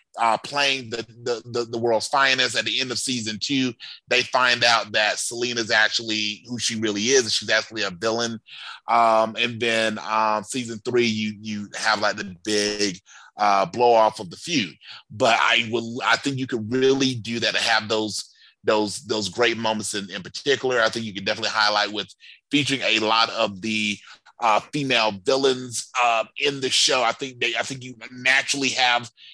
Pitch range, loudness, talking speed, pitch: 110-120 Hz, -22 LUFS, 190 wpm, 115 Hz